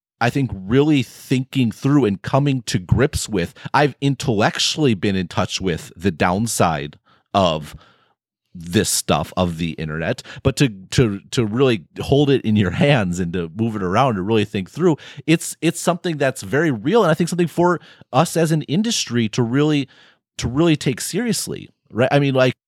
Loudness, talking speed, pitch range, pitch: -19 LUFS, 180 wpm, 110-150 Hz, 135 Hz